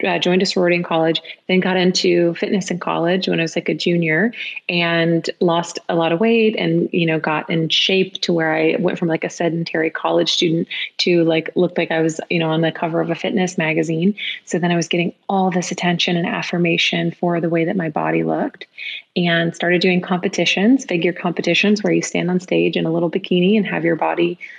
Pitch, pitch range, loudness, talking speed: 175 Hz, 165-180 Hz, -18 LUFS, 220 wpm